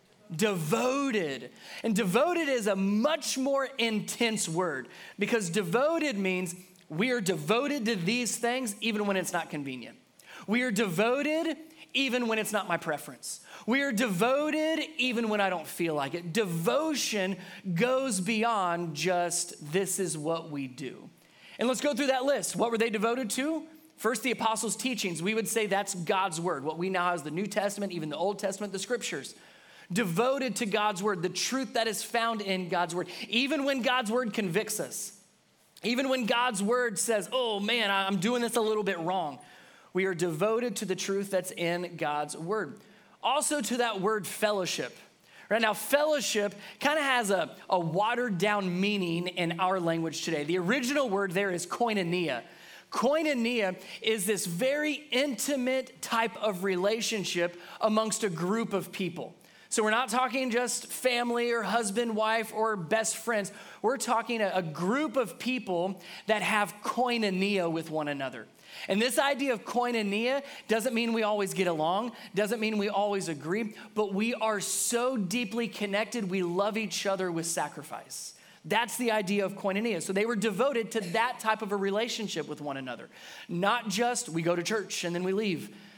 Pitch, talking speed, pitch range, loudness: 215 Hz, 170 wpm, 185-240 Hz, -29 LUFS